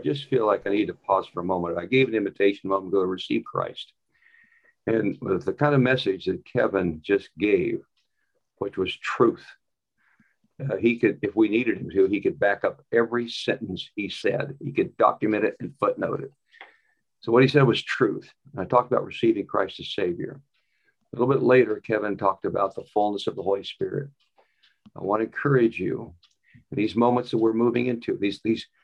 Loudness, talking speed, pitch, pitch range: -24 LUFS, 200 wpm, 120 Hz, 100-145 Hz